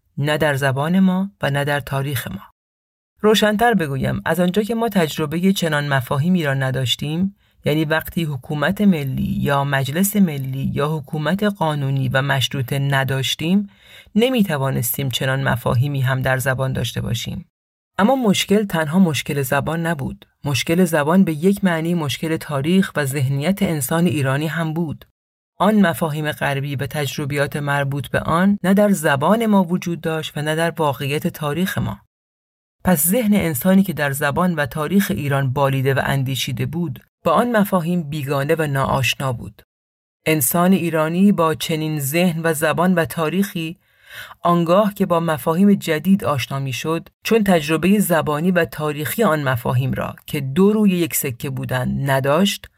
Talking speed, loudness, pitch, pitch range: 150 wpm, -19 LUFS, 155 Hz, 140-180 Hz